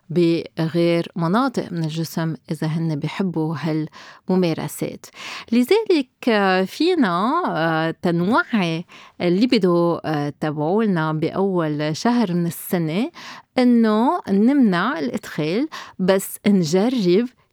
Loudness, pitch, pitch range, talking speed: -20 LUFS, 185 Hz, 165-235 Hz, 80 wpm